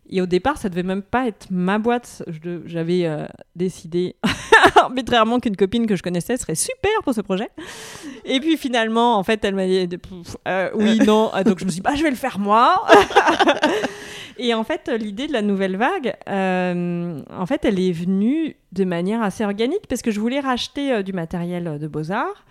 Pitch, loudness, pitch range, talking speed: 215 Hz, -20 LUFS, 185-250 Hz, 205 wpm